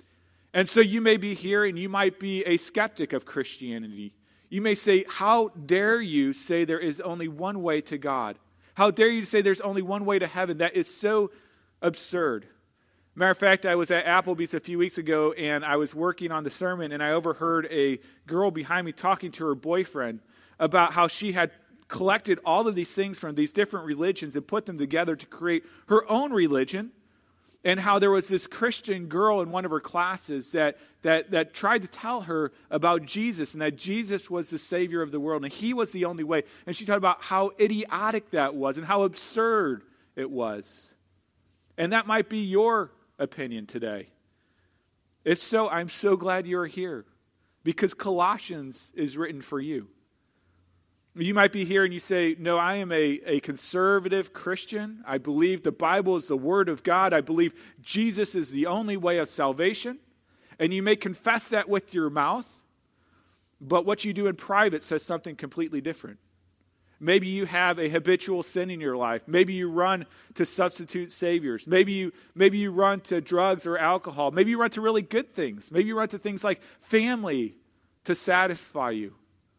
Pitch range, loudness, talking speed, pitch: 150-200 Hz, -26 LUFS, 190 wpm, 175 Hz